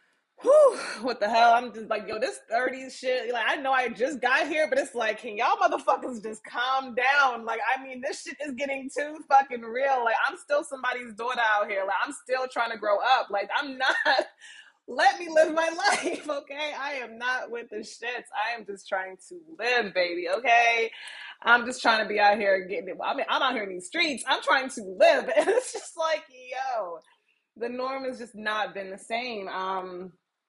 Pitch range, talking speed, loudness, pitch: 220-285 Hz, 215 wpm, -26 LUFS, 250 Hz